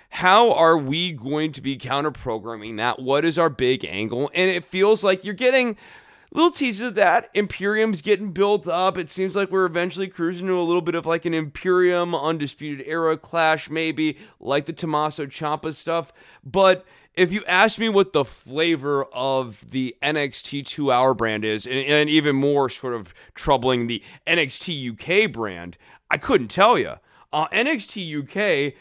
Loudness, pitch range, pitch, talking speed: -21 LUFS, 140-185 Hz, 160 Hz, 170 wpm